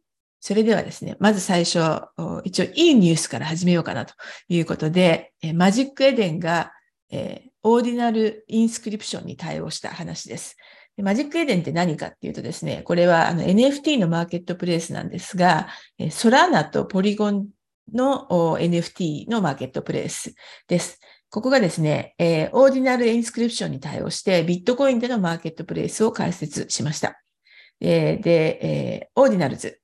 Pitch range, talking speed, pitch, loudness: 170-235 Hz, 380 characters per minute, 190 Hz, -21 LUFS